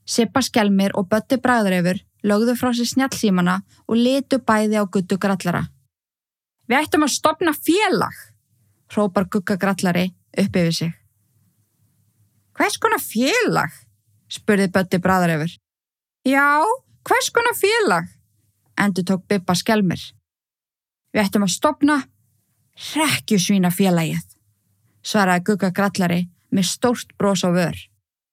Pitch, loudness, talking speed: 195 Hz, -19 LUFS, 110 wpm